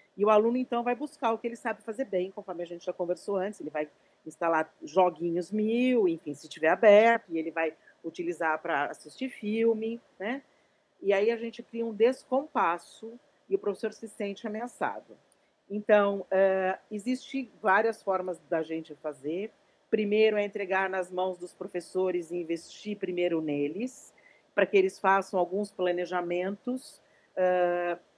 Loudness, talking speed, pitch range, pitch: -29 LUFS, 160 wpm, 175-225 Hz, 195 Hz